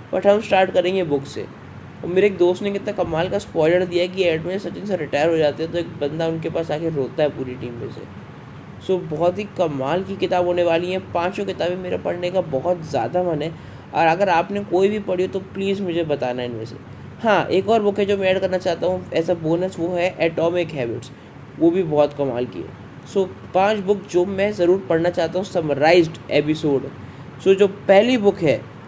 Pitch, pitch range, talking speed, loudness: 175 Hz, 150-190 Hz, 220 wpm, -20 LUFS